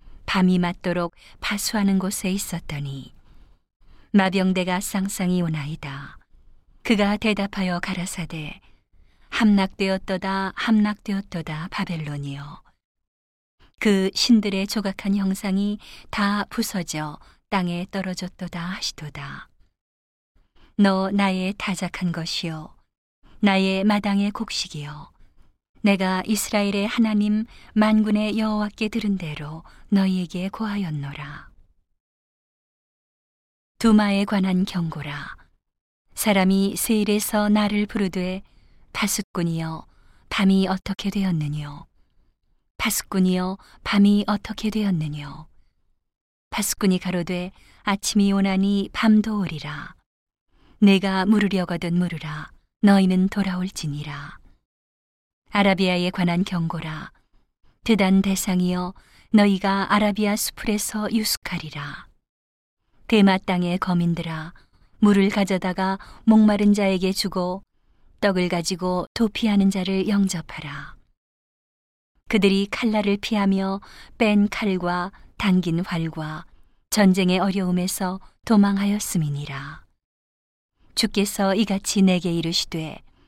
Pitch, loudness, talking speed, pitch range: 190 Hz, -22 LUFS, 235 characters per minute, 170-205 Hz